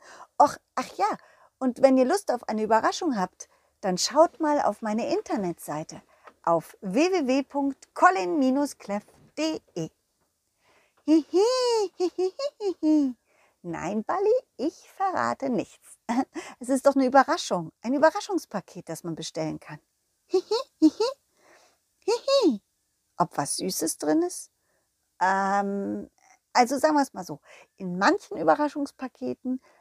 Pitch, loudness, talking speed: 275 Hz, -26 LUFS, 115 wpm